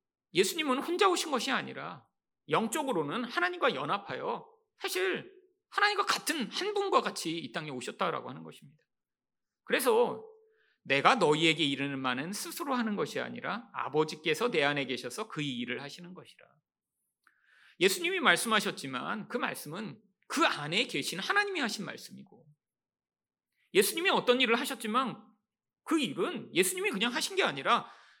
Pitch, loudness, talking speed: 255 Hz, -30 LUFS, 325 characters per minute